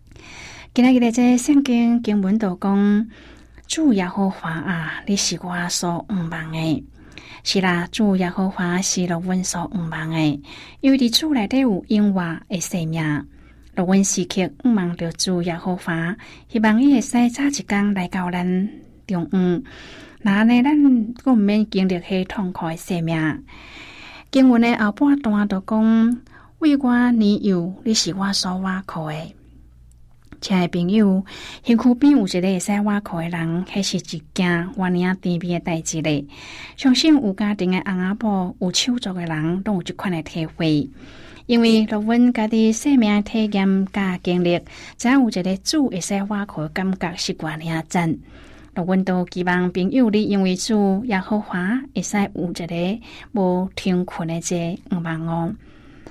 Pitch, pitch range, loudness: 190 Hz, 175-220 Hz, -20 LUFS